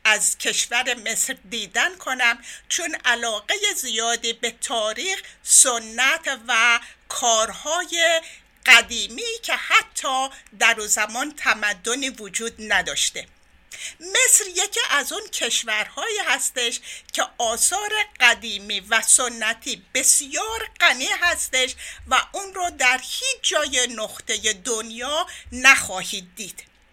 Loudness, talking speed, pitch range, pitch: -20 LUFS, 100 wpm, 225-340 Hz, 250 Hz